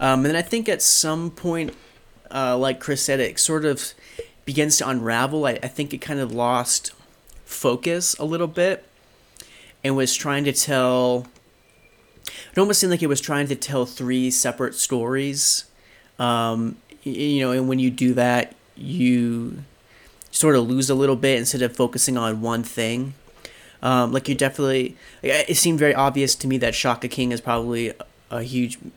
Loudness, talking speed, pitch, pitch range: -21 LUFS, 175 wpm, 130 Hz, 125-145 Hz